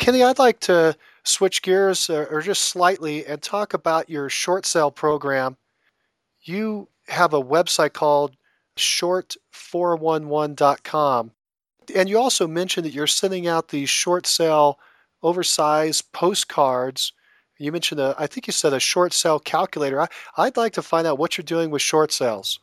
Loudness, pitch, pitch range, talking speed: -20 LUFS, 160 Hz, 150-180 Hz, 155 wpm